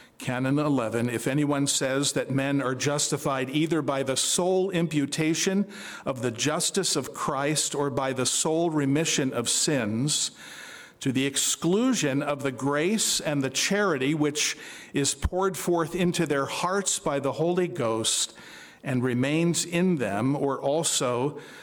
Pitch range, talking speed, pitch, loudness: 135-170 Hz, 145 wpm, 145 Hz, -25 LUFS